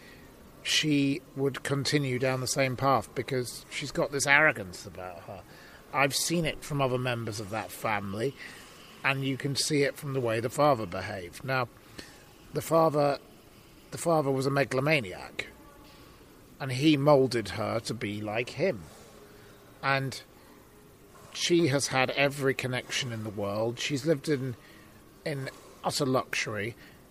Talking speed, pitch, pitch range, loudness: 145 wpm, 130 Hz, 110-140 Hz, -29 LUFS